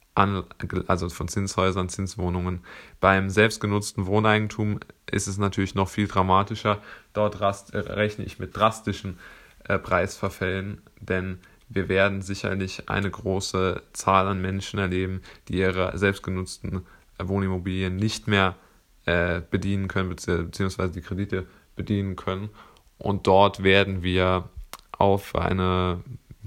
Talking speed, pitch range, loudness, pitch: 120 wpm, 95-100 Hz, -25 LUFS, 95 Hz